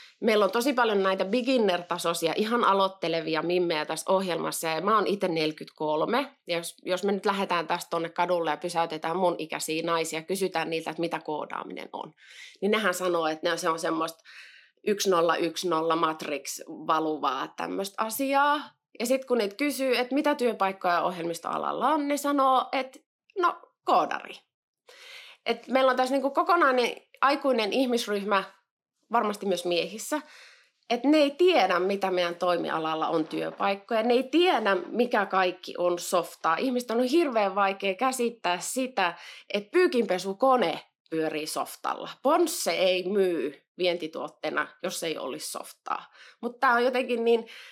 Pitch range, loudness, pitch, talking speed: 170-255 Hz, -27 LUFS, 195 Hz, 140 wpm